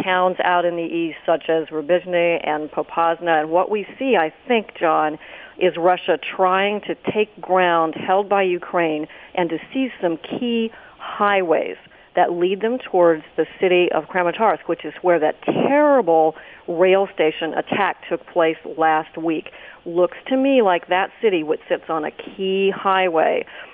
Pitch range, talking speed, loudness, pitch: 165-195 Hz, 160 wpm, -20 LUFS, 180 Hz